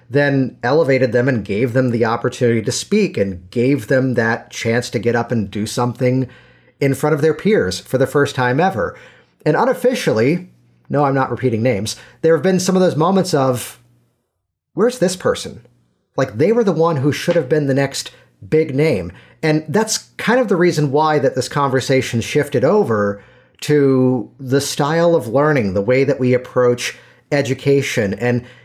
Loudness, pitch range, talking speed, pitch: -17 LUFS, 120-155 Hz, 180 wpm, 130 Hz